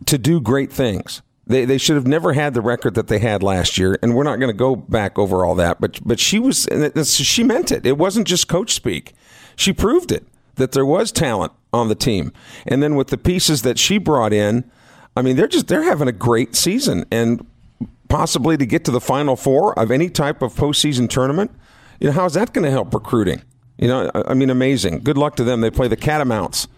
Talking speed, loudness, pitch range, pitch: 240 wpm, -17 LUFS, 120-150 Hz, 135 Hz